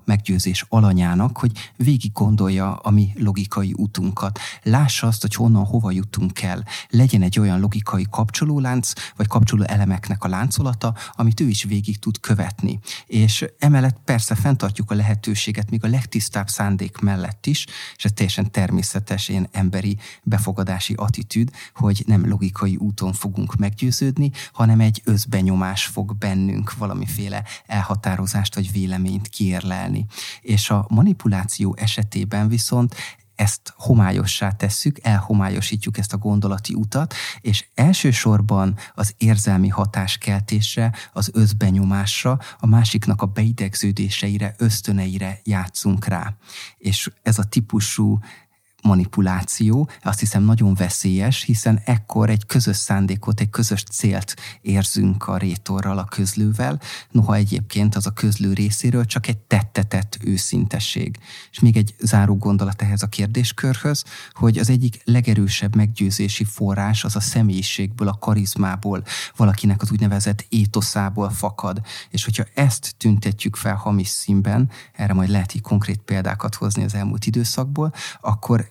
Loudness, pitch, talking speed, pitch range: -20 LUFS, 105 Hz, 130 wpm, 100-115 Hz